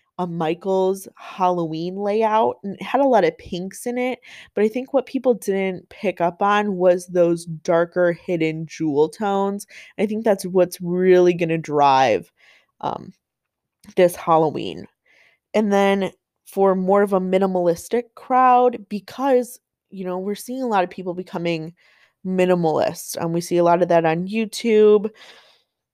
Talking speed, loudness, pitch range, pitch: 150 wpm, -20 LUFS, 175-210 Hz, 190 Hz